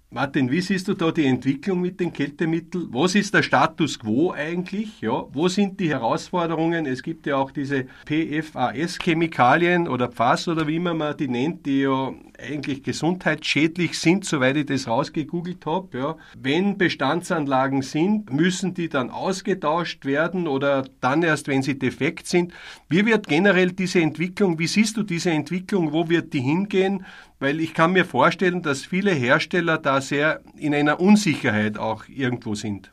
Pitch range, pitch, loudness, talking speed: 140-180 Hz, 160 Hz, -22 LUFS, 165 wpm